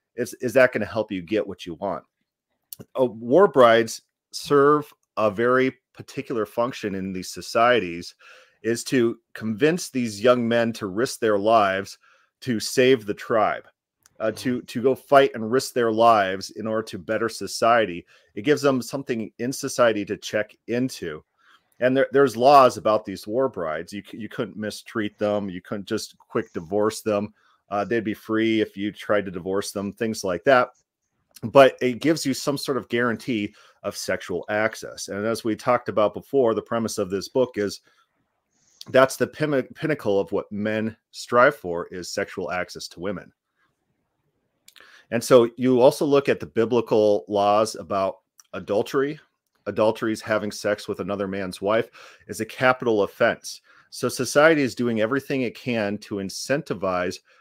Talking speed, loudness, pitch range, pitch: 165 wpm, -23 LUFS, 105-130 Hz, 110 Hz